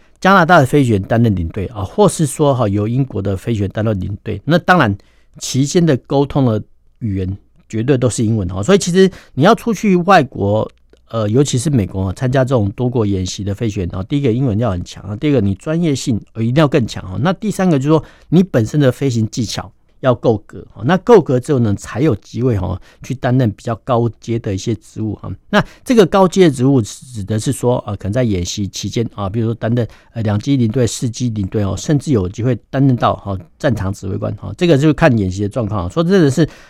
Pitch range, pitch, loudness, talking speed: 100-145 Hz, 120 Hz, -15 LUFS, 330 characters per minute